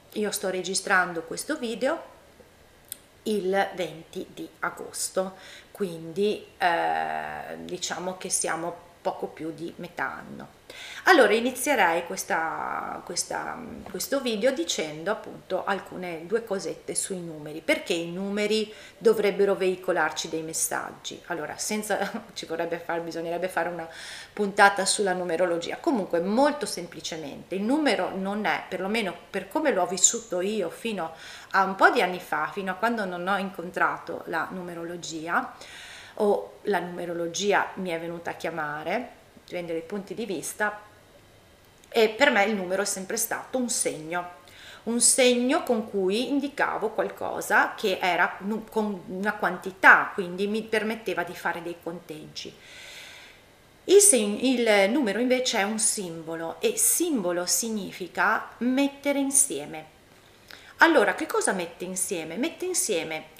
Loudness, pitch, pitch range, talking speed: -26 LUFS, 195 Hz, 175-230 Hz, 130 wpm